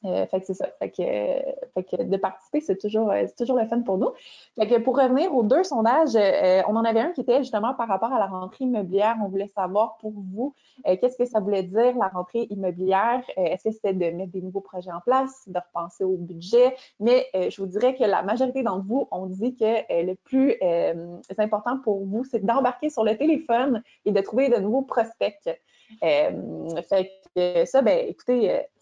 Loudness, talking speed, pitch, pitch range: -24 LUFS, 220 wpm, 225 Hz, 190-255 Hz